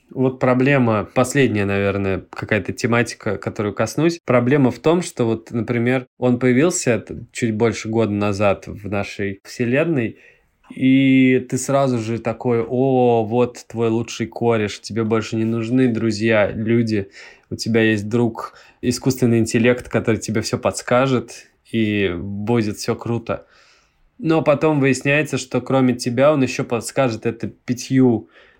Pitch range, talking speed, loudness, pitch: 110-130 Hz, 135 wpm, -19 LUFS, 120 Hz